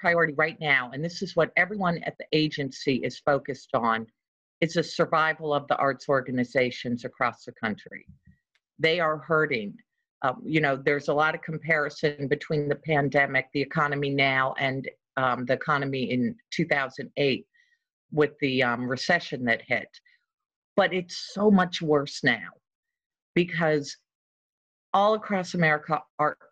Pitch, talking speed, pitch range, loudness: 150 Hz, 145 wpm, 135-170 Hz, -26 LUFS